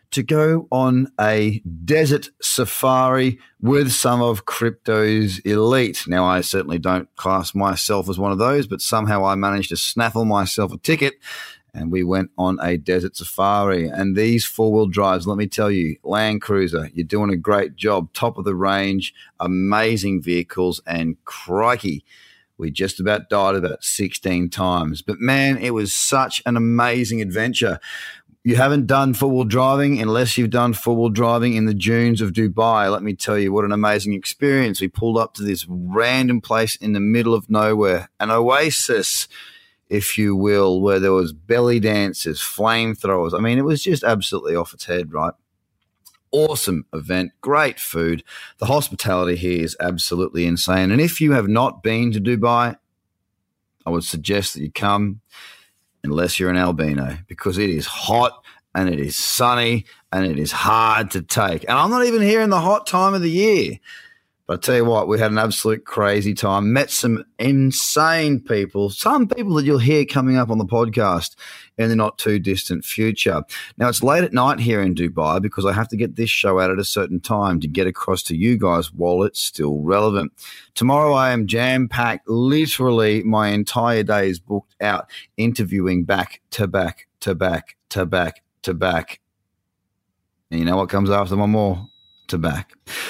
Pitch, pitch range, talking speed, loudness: 105 Hz, 95-120 Hz, 180 wpm, -19 LUFS